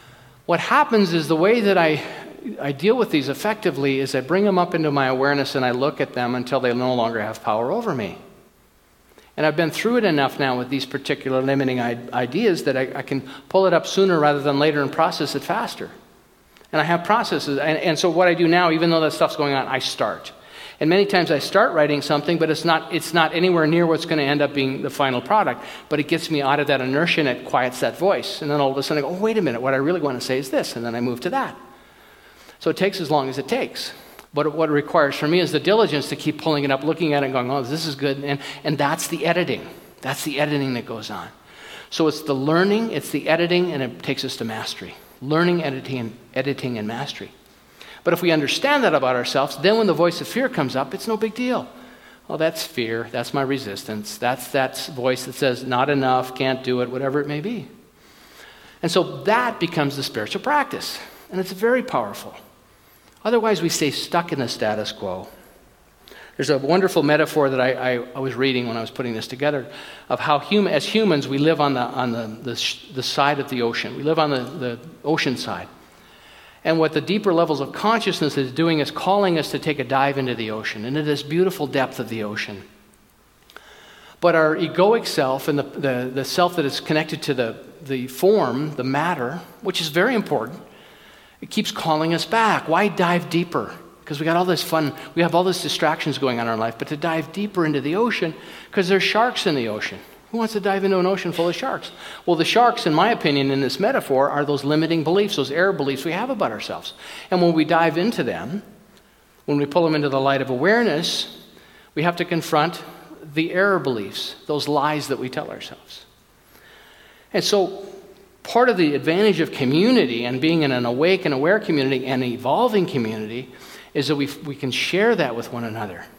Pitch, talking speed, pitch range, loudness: 150 Hz, 225 wpm, 135-175 Hz, -21 LUFS